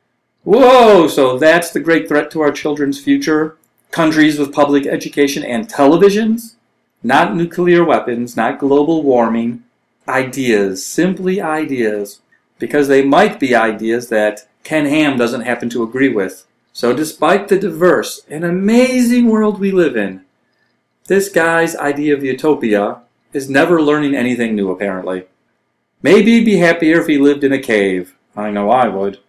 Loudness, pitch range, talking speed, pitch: -13 LUFS, 120-170 Hz, 150 wpm, 145 Hz